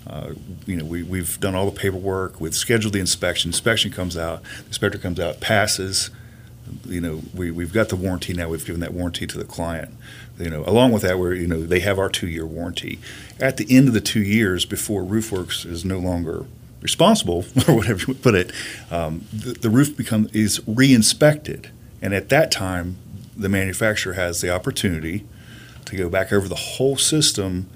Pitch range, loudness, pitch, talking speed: 90-115 Hz, -21 LUFS, 100 Hz, 195 wpm